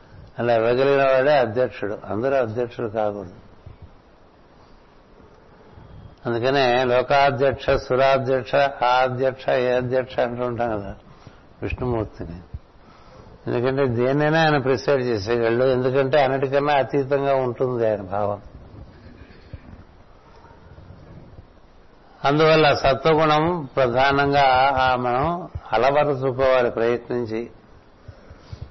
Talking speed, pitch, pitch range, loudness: 75 wpm, 130 Hz, 115-140 Hz, -20 LUFS